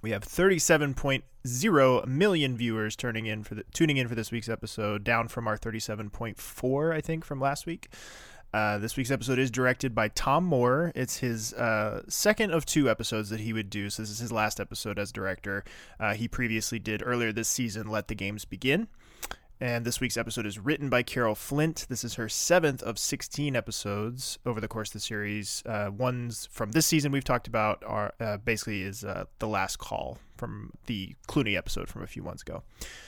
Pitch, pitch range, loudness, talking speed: 115 Hz, 110-130 Hz, -29 LUFS, 205 wpm